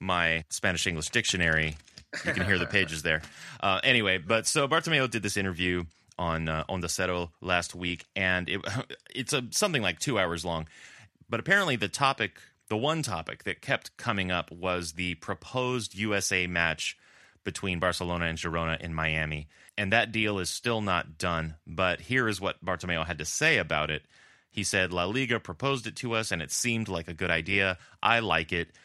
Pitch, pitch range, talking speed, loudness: 90 Hz, 85-110 Hz, 190 wpm, -28 LUFS